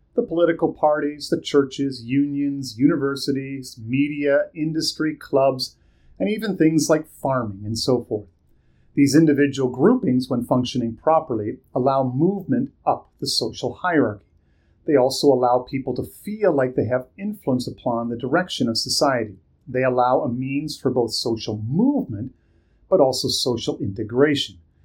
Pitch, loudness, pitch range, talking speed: 135 Hz, -21 LUFS, 125-150 Hz, 140 wpm